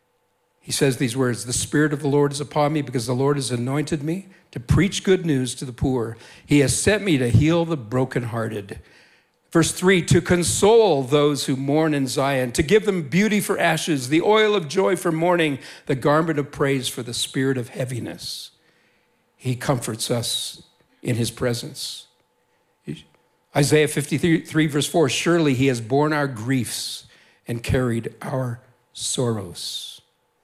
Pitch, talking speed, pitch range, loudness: 145 Hz, 165 wpm, 125-160 Hz, -21 LUFS